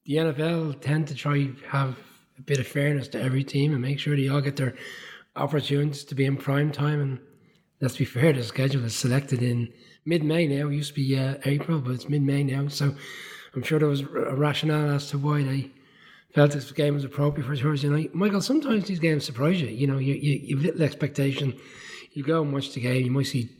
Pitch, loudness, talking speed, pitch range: 145 Hz, -26 LUFS, 230 wpm, 135-150 Hz